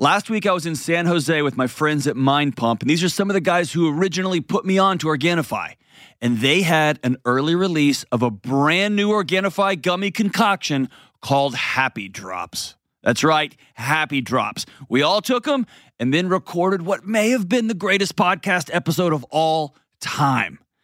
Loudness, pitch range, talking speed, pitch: -20 LUFS, 140-195 Hz, 185 wpm, 165 Hz